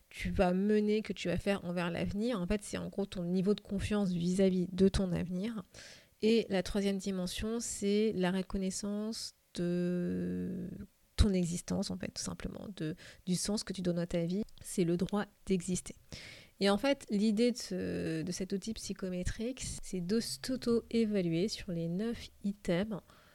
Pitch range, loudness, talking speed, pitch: 180-210 Hz, -34 LUFS, 170 wpm, 195 Hz